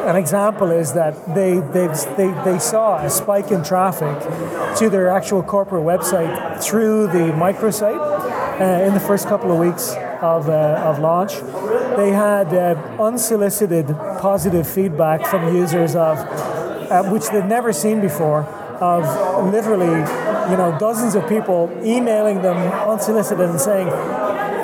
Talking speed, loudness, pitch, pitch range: 145 wpm, -18 LUFS, 190 Hz, 170-205 Hz